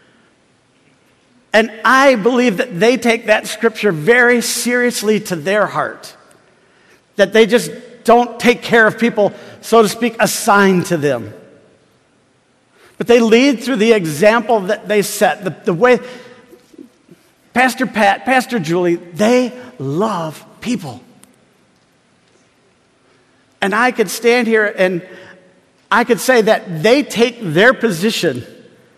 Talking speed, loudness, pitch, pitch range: 125 wpm, -14 LUFS, 220 Hz, 185-240 Hz